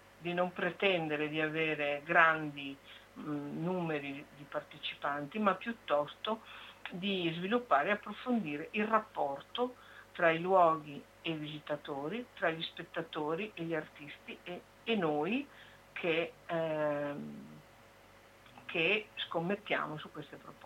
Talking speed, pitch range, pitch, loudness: 115 wpm, 145-185 Hz, 160 Hz, -34 LUFS